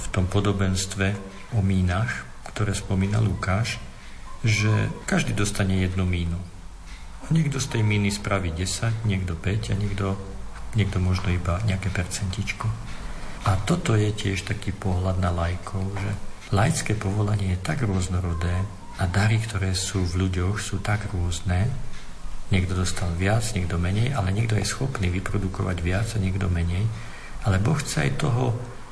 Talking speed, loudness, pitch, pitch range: 145 wpm, -25 LUFS, 100 Hz, 95-110 Hz